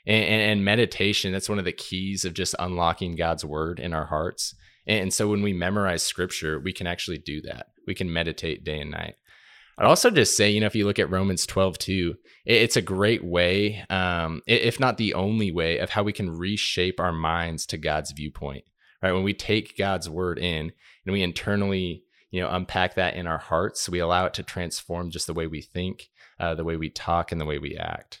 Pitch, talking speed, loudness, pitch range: 90 Hz, 220 wpm, -25 LUFS, 85-95 Hz